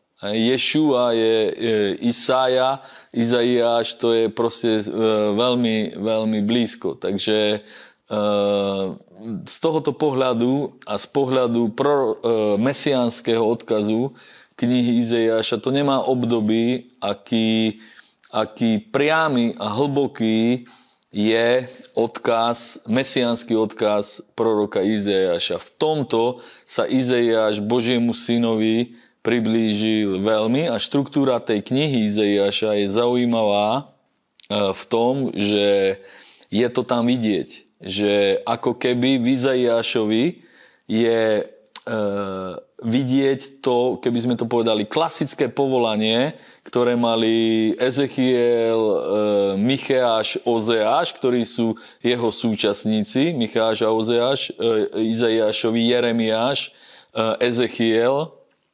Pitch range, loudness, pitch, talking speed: 110-125 Hz, -20 LUFS, 115 Hz, 90 wpm